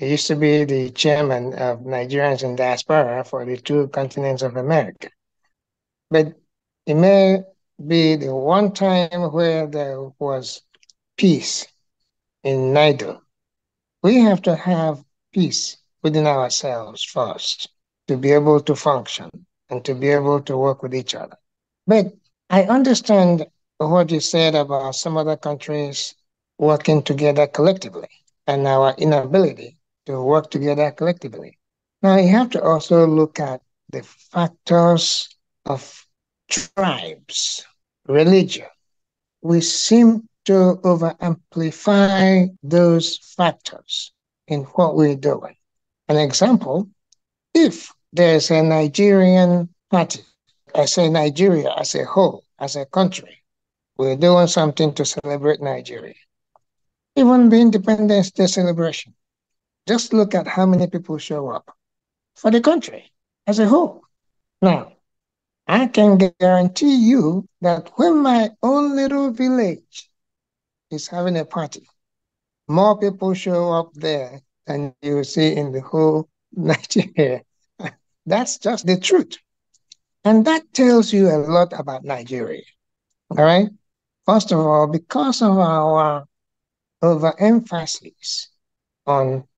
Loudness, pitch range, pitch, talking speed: -18 LUFS, 145-190 Hz, 165 Hz, 125 wpm